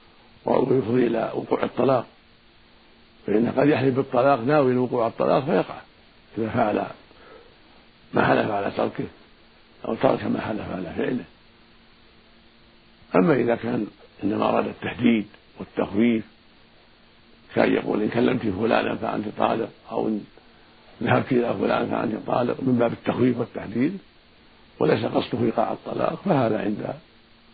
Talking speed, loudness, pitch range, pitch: 120 wpm, -24 LUFS, 110-125 Hz, 115 Hz